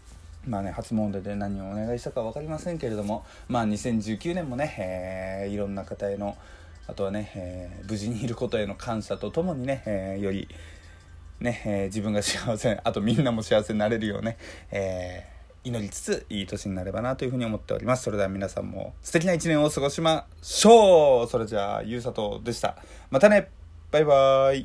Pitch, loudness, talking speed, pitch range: 105 Hz, -26 LUFS, 375 characters per minute, 95-125 Hz